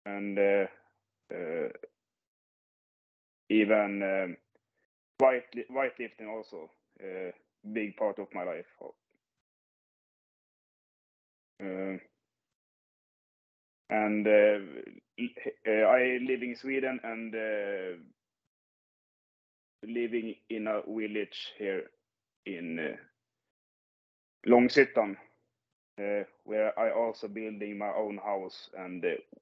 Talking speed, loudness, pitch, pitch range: 85 wpm, -31 LUFS, 110 Hz, 100-125 Hz